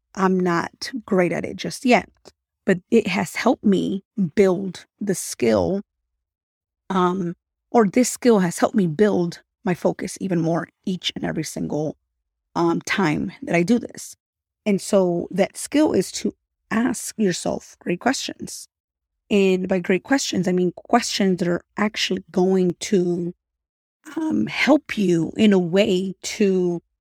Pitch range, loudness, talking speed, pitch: 175-215 Hz, -21 LUFS, 145 wpm, 190 Hz